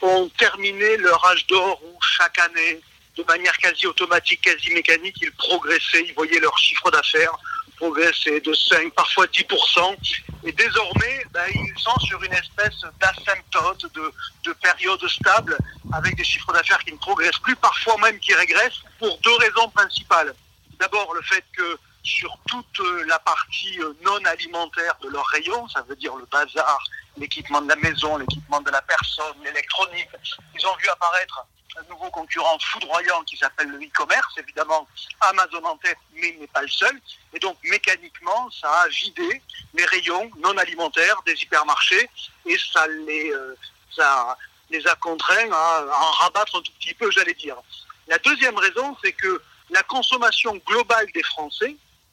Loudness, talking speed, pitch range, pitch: -20 LUFS, 165 wpm, 165-255 Hz, 185 Hz